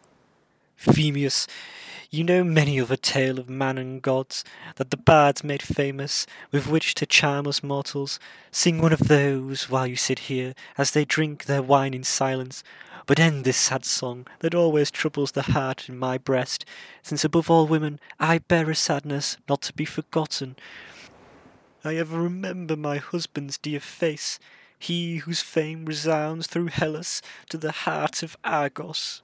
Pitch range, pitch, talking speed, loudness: 135-160 Hz, 145 Hz, 165 wpm, -24 LUFS